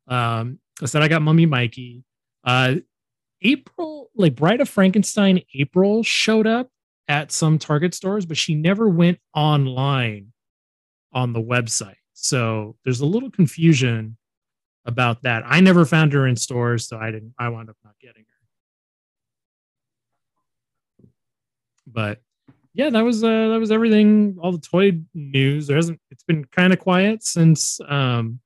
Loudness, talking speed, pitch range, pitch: -19 LUFS, 150 wpm, 120-180 Hz, 140 Hz